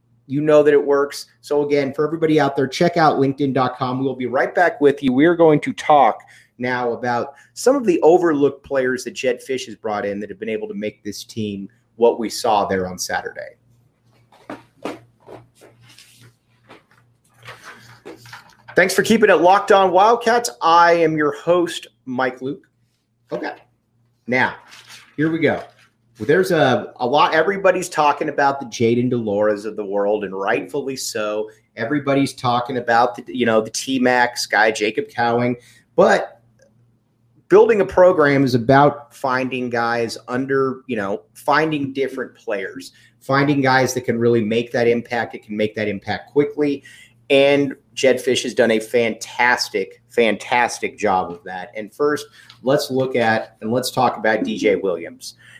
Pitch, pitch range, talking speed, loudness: 125 Hz, 115-145 Hz, 160 wpm, -18 LUFS